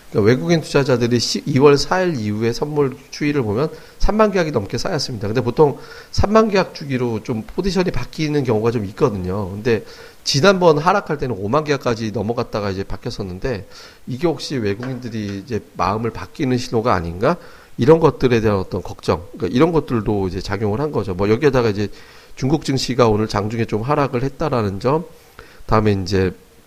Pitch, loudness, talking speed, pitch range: 125 Hz, -19 LUFS, 370 characters per minute, 105-150 Hz